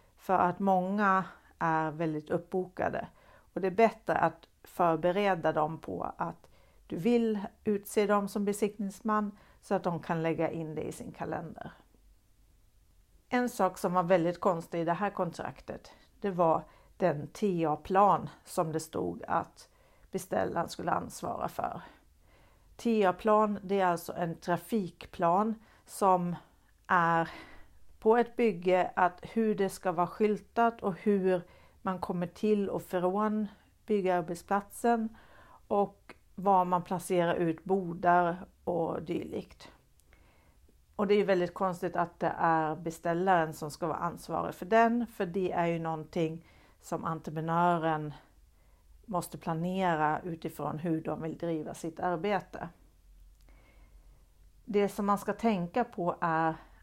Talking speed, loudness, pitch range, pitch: 130 wpm, -31 LUFS, 165-200 Hz, 180 Hz